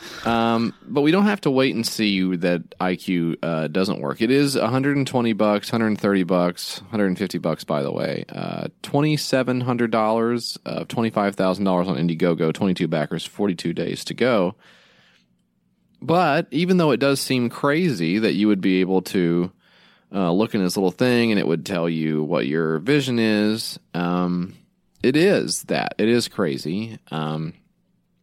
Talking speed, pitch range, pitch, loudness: 155 wpm, 90-120 Hz, 105 Hz, -21 LUFS